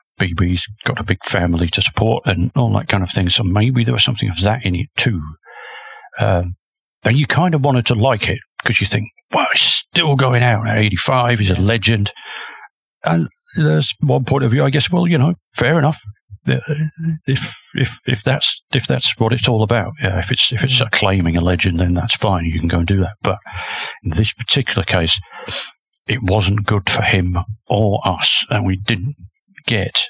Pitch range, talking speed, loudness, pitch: 95-125 Hz, 205 wpm, -16 LUFS, 105 Hz